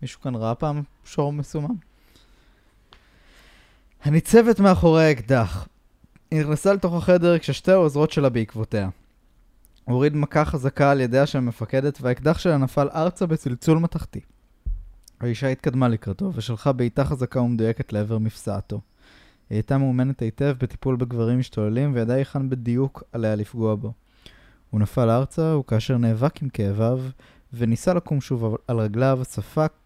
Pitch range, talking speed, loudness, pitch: 115-150 Hz, 130 wpm, -22 LUFS, 130 Hz